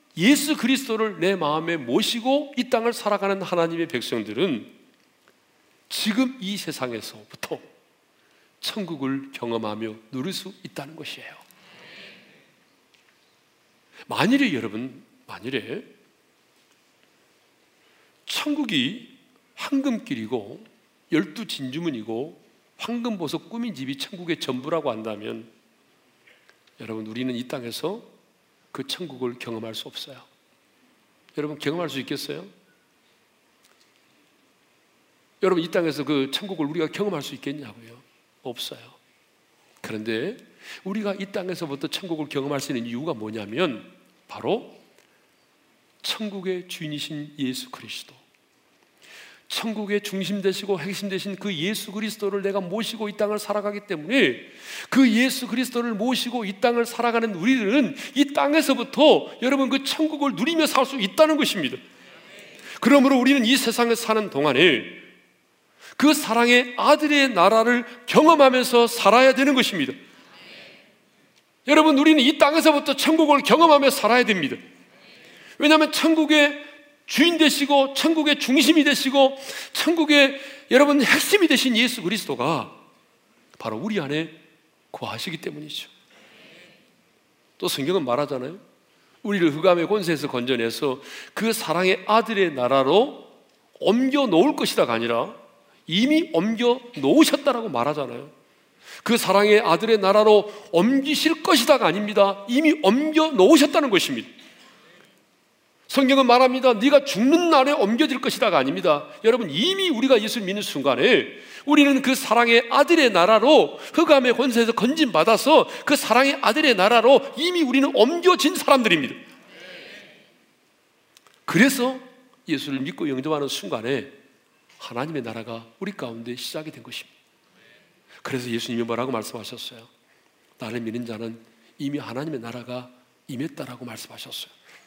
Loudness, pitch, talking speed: -21 LUFS, 225 Hz, 290 characters per minute